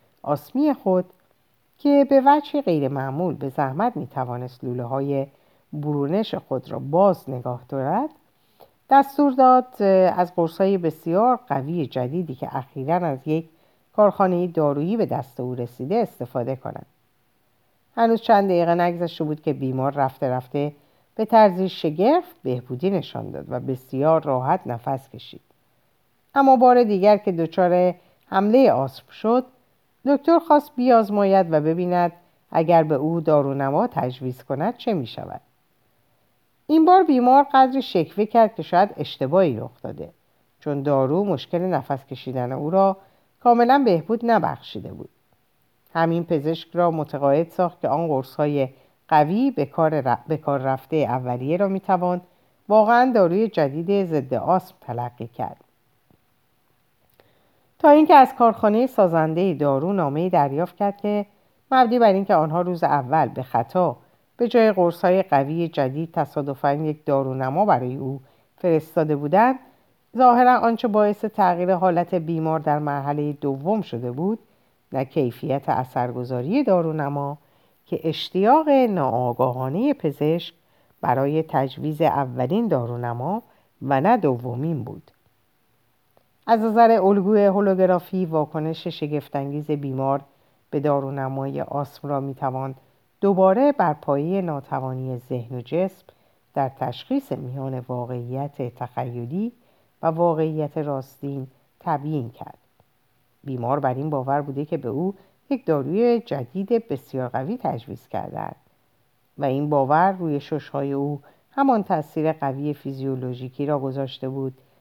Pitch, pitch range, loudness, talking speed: 155 Hz, 135-195 Hz, -21 LUFS, 125 wpm